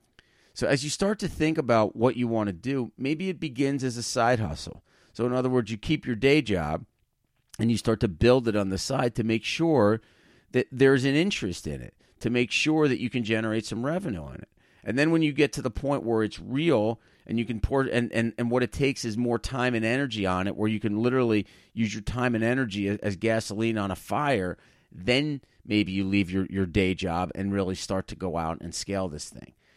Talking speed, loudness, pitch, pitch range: 235 wpm, -26 LUFS, 115 Hz, 100-130 Hz